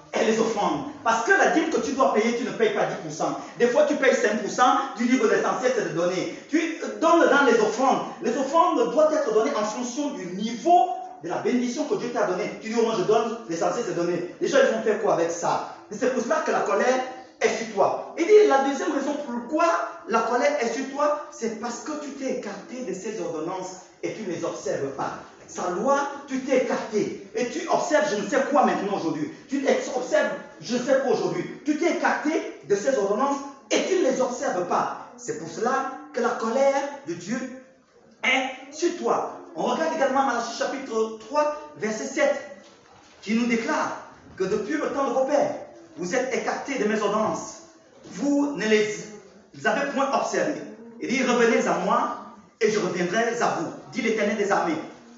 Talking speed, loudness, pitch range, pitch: 205 wpm, -24 LUFS, 220-285 Hz, 250 Hz